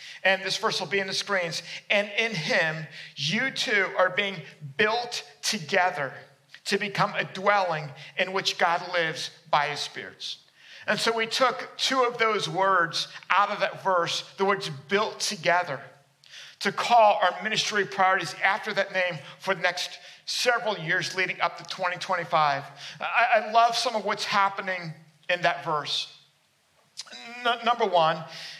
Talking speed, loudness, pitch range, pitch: 155 wpm, -25 LUFS, 170-210 Hz, 185 Hz